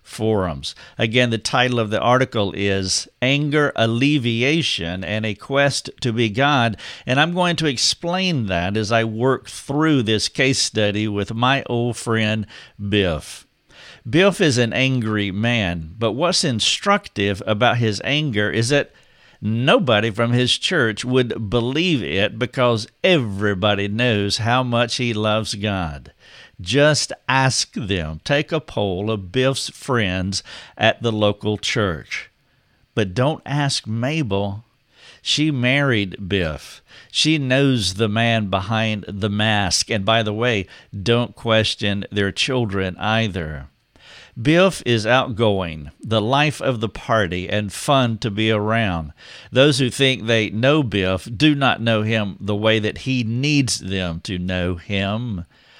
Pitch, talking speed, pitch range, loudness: 115 Hz, 140 wpm, 100-130 Hz, -19 LUFS